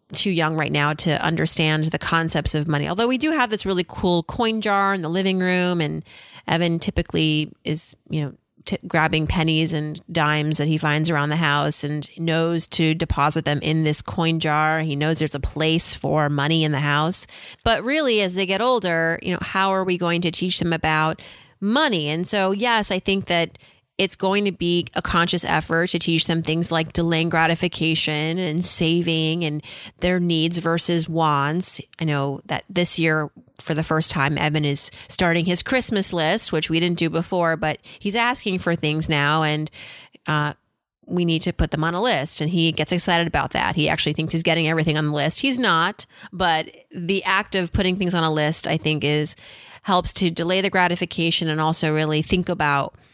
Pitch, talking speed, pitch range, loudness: 165 Hz, 200 wpm, 155-180 Hz, -21 LUFS